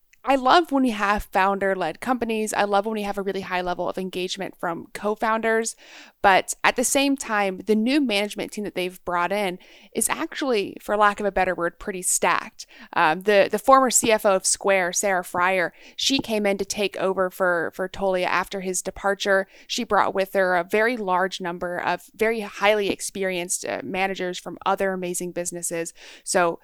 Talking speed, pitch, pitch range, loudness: 185 wpm, 195 Hz, 180-215 Hz, -23 LUFS